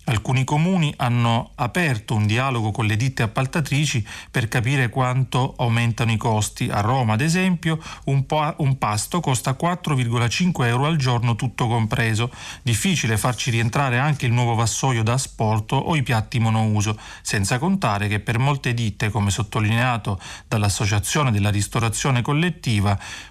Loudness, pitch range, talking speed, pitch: -21 LUFS, 110-140 Hz, 145 wpm, 125 Hz